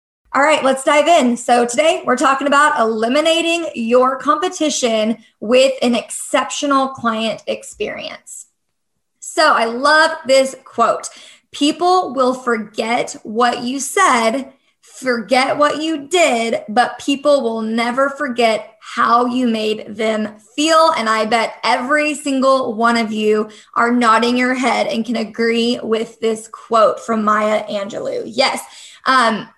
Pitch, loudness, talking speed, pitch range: 250 Hz, -16 LUFS, 135 wpm, 225-295 Hz